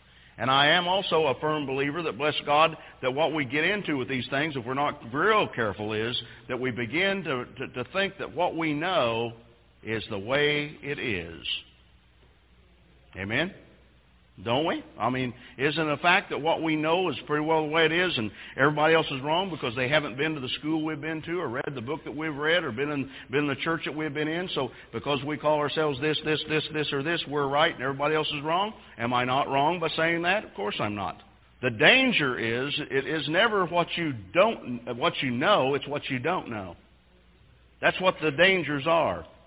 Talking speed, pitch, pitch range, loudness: 220 wpm, 145 Hz, 125-160 Hz, -26 LUFS